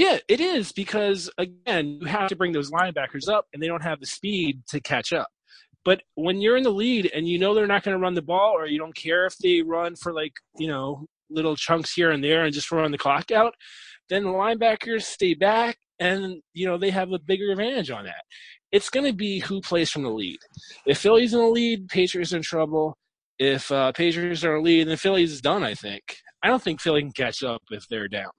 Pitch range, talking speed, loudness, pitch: 155-200 Hz, 245 wpm, -24 LUFS, 180 Hz